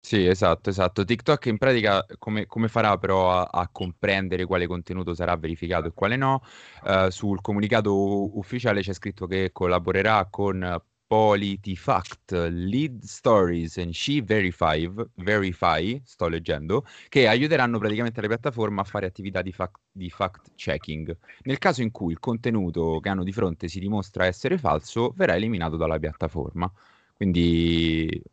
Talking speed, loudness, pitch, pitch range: 150 wpm, -25 LUFS, 95 Hz, 90-110 Hz